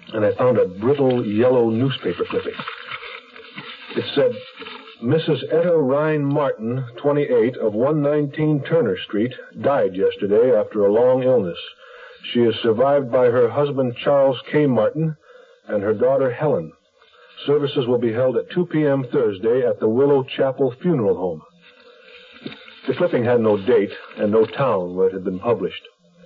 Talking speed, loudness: 150 wpm, -19 LUFS